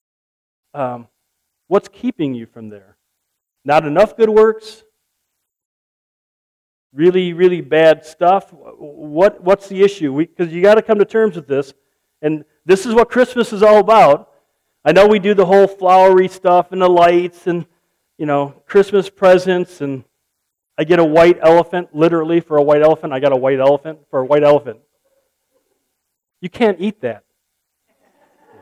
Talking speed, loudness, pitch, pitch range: 155 wpm, -13 LUFS, 175 Hz, 145-200 Hz